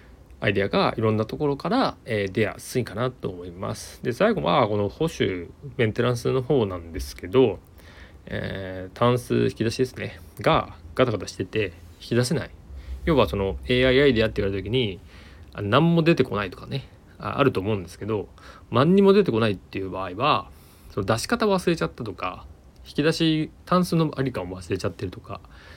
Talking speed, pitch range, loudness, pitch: 370 characters per minute, 95-130 Hz, -24 LUFS, 105 Hz